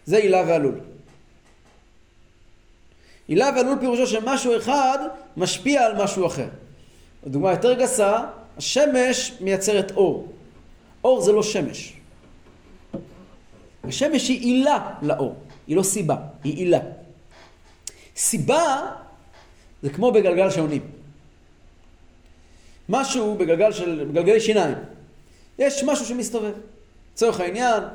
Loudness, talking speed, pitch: -21 LUFS, 100 wpm, 205 Hz